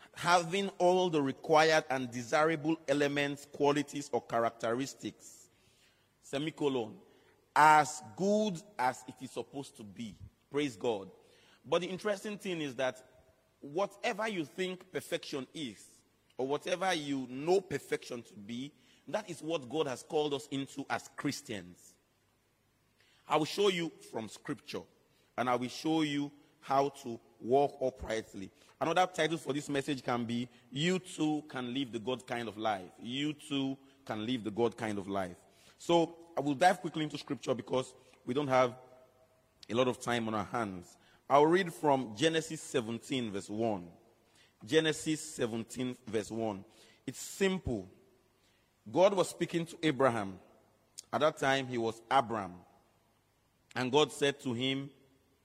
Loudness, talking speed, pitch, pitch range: -33 LUFS, 145 wpm, 135 Hz, 115-155 Hz